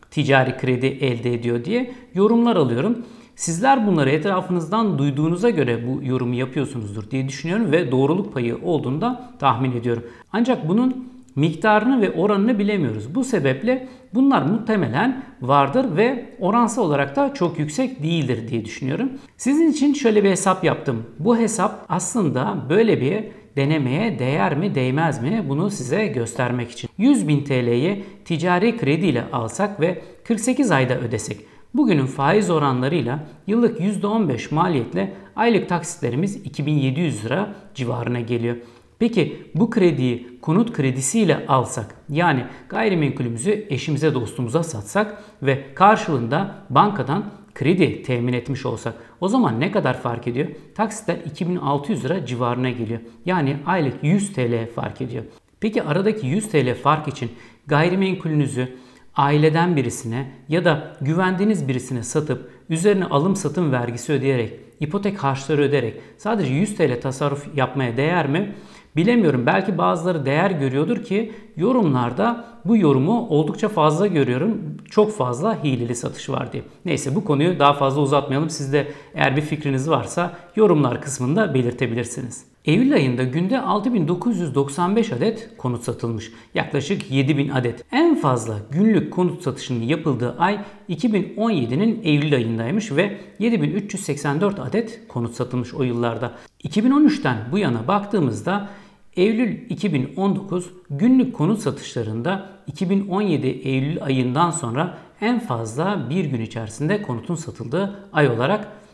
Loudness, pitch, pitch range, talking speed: -21 LUFS, 155 Hz, 130-205 Hz, 130 wpm